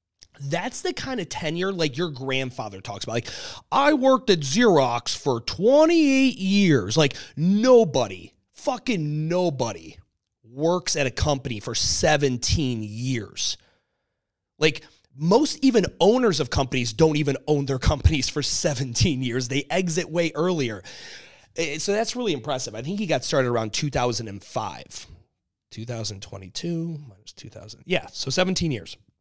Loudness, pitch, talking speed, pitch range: -23 LUFS, 145 Hz, 135 wpm, 120-180 Hz